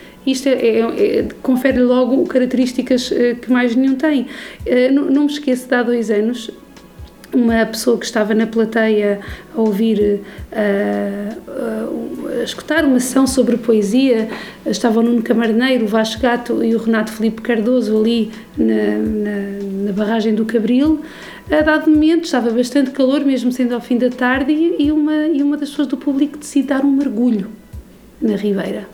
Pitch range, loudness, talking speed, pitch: 220-270 Hz, -16 LUFS, 175 wpm, 245 Hz